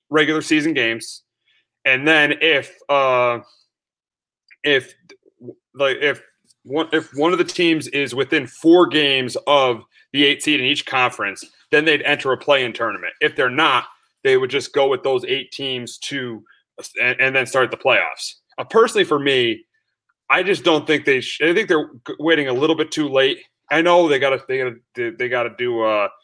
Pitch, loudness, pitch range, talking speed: 145 Hz, -18 LUFS, 130-175 Hz, 185 wpm